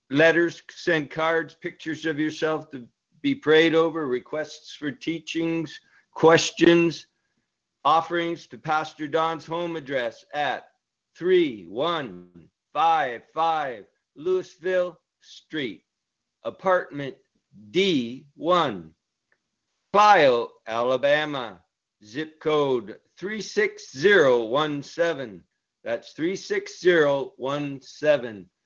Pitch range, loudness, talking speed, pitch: 145-180 Hz, -24 LUFS, 70 wpm, 160 Hz